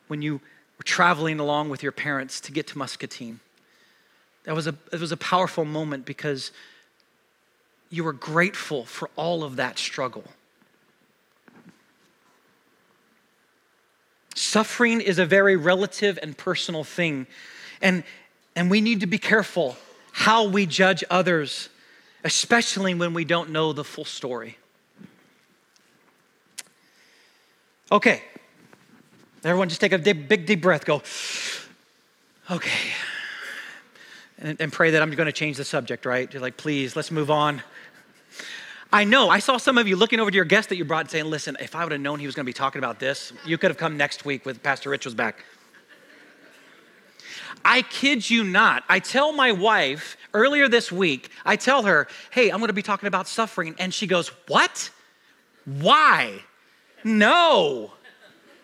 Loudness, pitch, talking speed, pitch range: -22 LUFS, 175 Hz, 155 wpm, 150-215 Hz